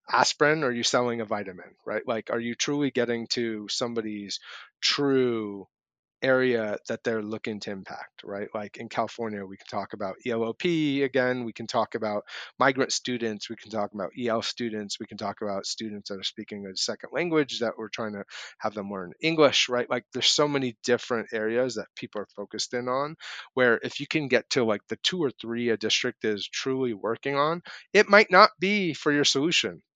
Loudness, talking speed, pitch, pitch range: -26 LUFS, 200 wpm, 115 Hz, 110-130 Hz